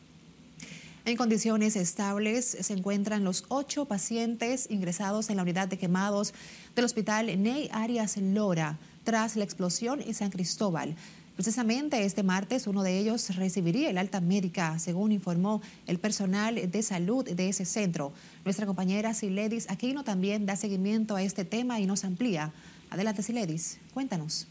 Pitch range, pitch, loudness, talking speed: 185-220 Hz, 200 Hz, -30 LUFS, 145 wpm